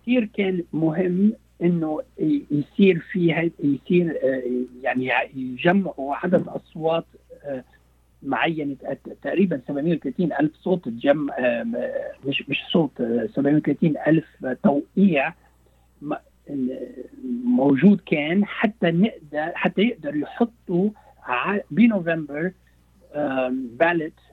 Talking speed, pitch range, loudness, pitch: 80 wpm, 140-205 Hz, -23 LUFS, 170 Hz